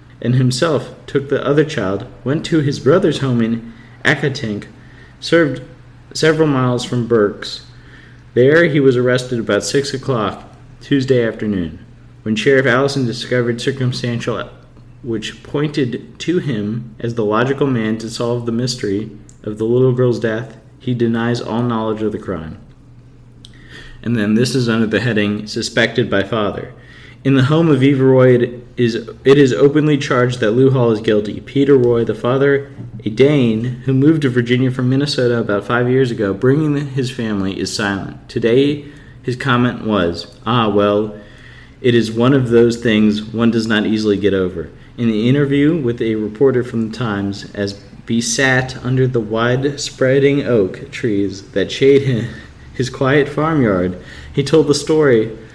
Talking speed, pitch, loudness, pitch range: 160 wpm, 125 Hz, -16 LUFS, 110-135 Hz